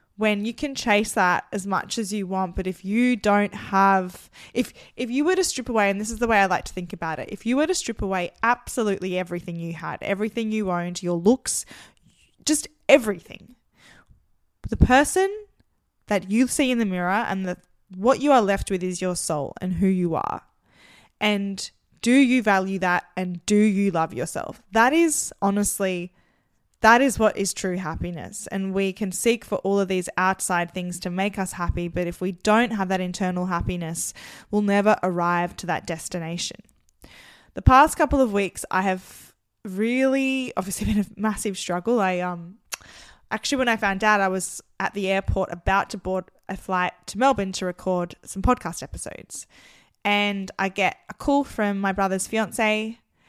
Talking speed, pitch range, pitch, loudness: 185 wpm, 185-225 Hz, 195 Hz, -23 LUFS